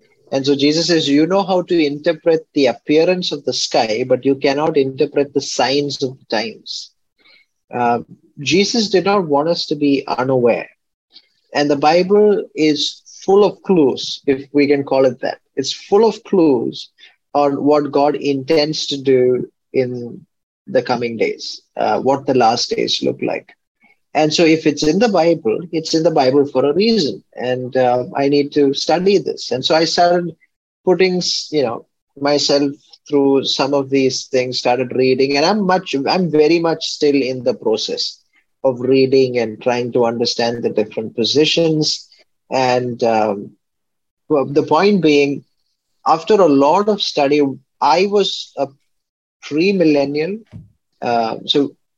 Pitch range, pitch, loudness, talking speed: 135-170 Hz, 145 Hz, -16 LUFS, 160 wpm